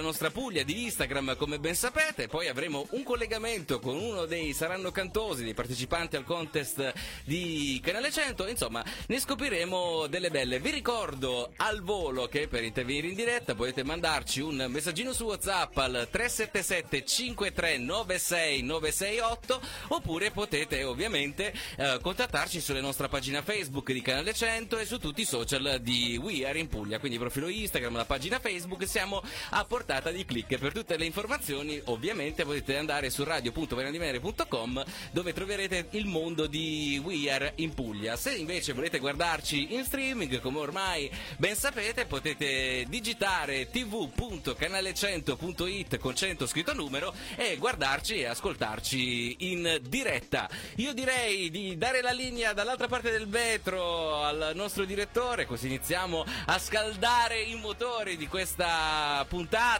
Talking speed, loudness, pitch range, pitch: 145 wpm, -31 LUFS, 140-215 Hz, 165 Hz